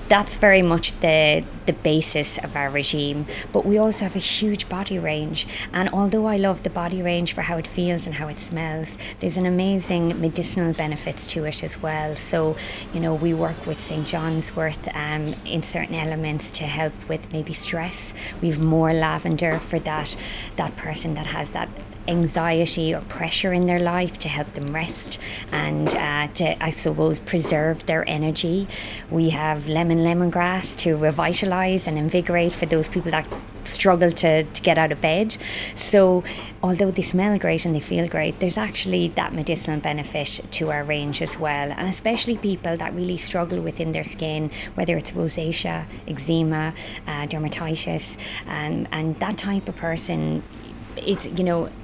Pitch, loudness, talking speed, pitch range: 160 Hz, -23 LUFS, 170 wpm, 155-180 Hz